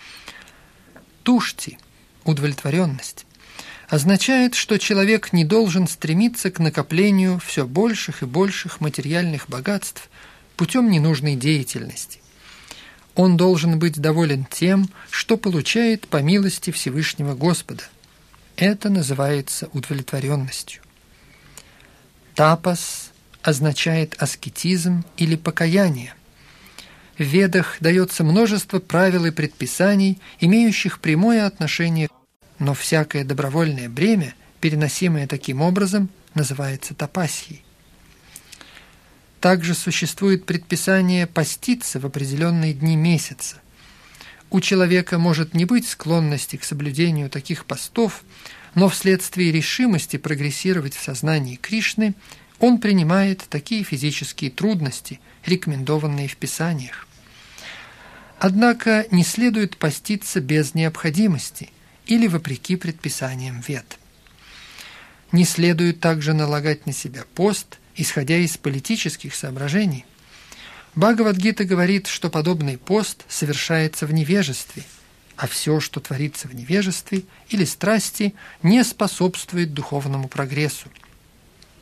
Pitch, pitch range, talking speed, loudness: 165 Hz, 145-190 Hz, 95 wpm, -20 LUFS